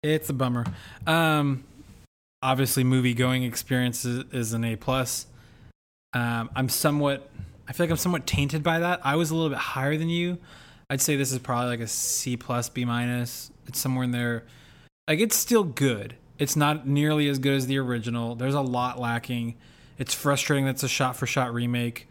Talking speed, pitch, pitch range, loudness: 190 wpm, 130 Hz, 120-145 Hz, -26 LUFS